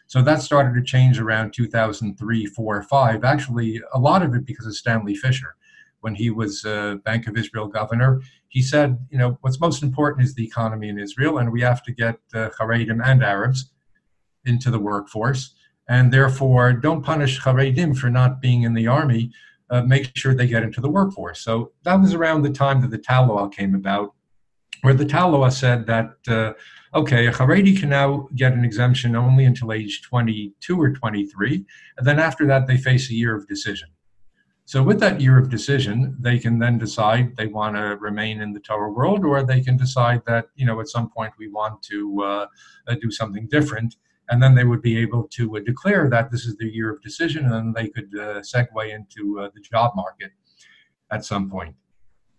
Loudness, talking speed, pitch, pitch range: -20 LUFS, 200 wpm, 120 Hz, 110-130 Hz